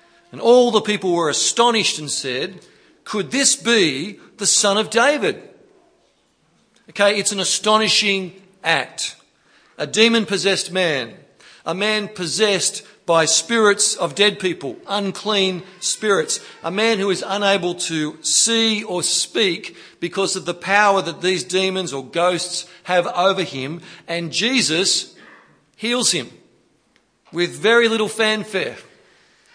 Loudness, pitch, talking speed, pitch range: -18 LUFS, 195 Hz, 130 wpm, 175-215 Hz